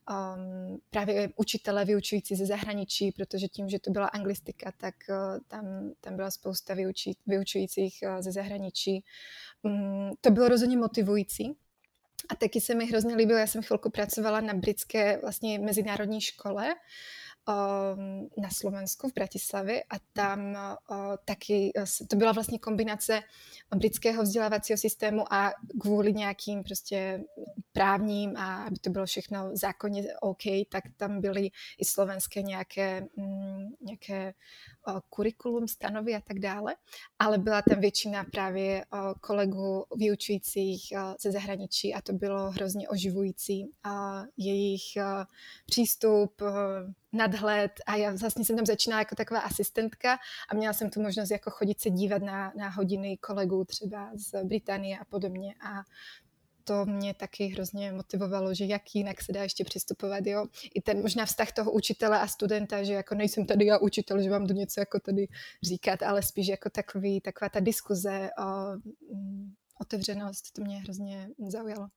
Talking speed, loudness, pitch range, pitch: 145 wpm, -31 LUFS, 195-215 Hz, 200 Hz